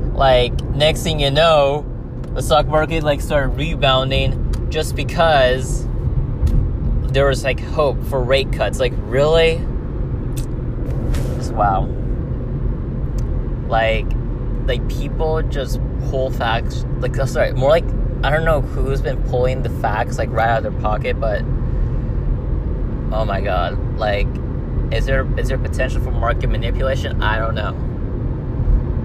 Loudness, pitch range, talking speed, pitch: -19 LUFS, 125-140 Hz, 130 wpm, 130 Hz